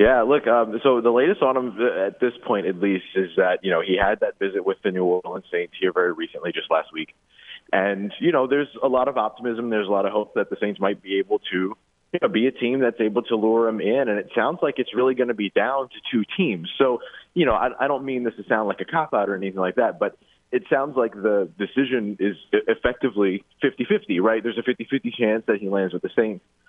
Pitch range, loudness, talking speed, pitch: 100-135 Hz, -22 LUFS, 260 wpm, 120 Hz